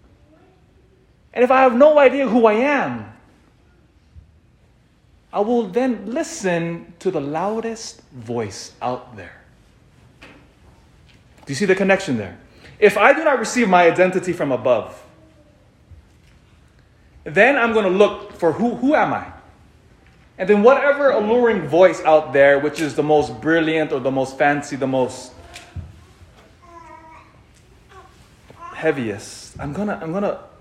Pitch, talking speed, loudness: 180 Hz, 130 wpm, -18 LUFS